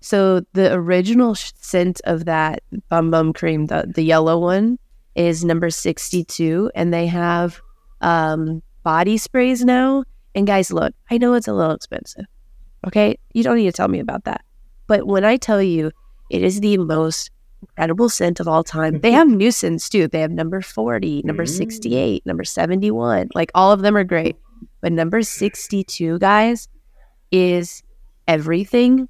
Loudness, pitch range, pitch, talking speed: -18 LUFS, 165-210 Hz, 180 Hz, 165 wpm